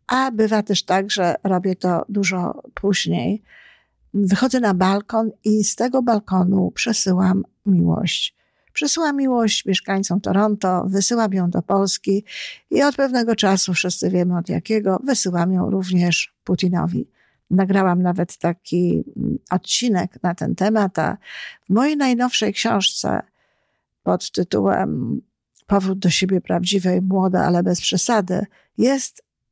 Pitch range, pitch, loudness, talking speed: 185-220 Hz, 195 Hz, -19 LUFS, 120 wpm